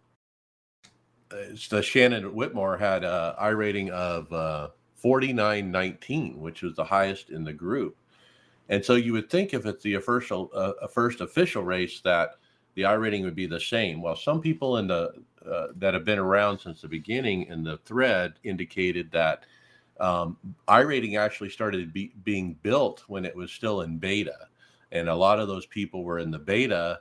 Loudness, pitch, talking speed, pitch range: -27 LUFS, 100 Hz, 185 wpm, 85-105 Hz